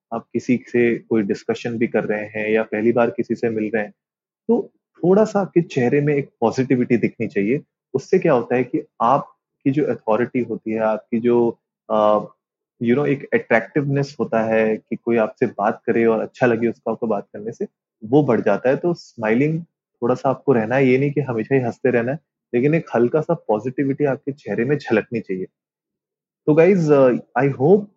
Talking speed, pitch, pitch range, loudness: 200 wpm, 120 Hz, 115-145 Hz, -20 LUFS